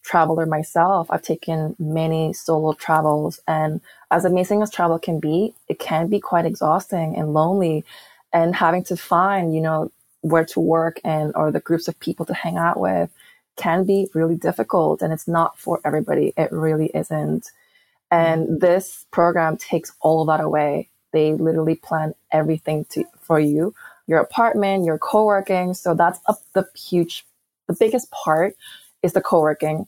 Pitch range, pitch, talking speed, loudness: 155-180 Hz, 165 Hz, 165 wpm, -20 LUFS